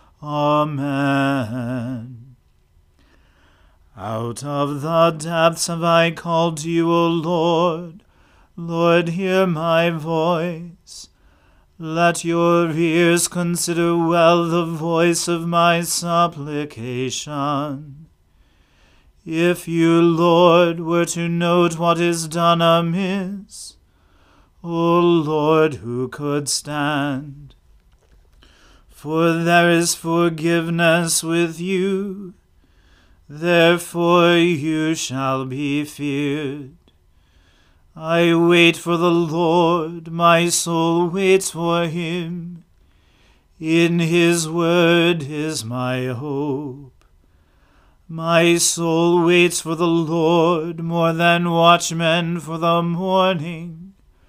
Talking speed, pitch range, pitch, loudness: 85 wpm, 135-170 Hz, 165 Hz, -18 LUFS